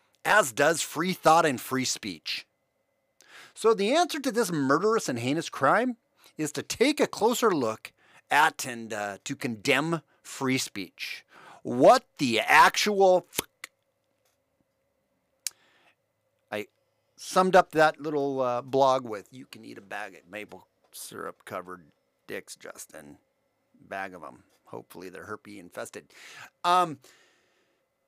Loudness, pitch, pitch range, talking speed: -25 LUFS, 145 Hz, 130-185 Hz, 120 wpm